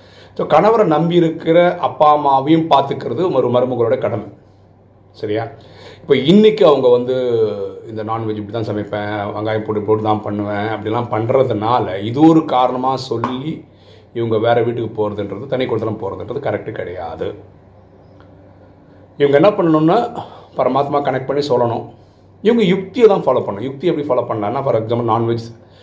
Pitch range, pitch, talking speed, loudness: 105-145 Hz, 120 Hz, 130 wpm, -16 LUFS